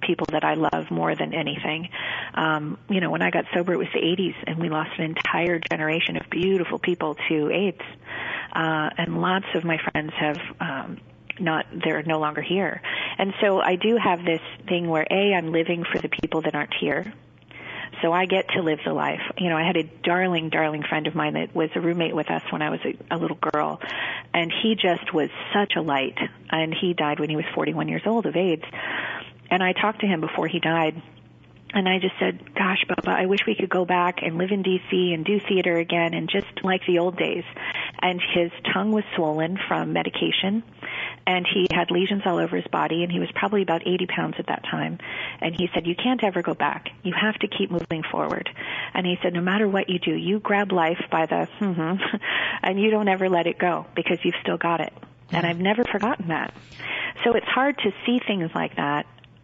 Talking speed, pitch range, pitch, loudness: 220 wpm, 160-190 Hz, 175 Hz, -24 LUFS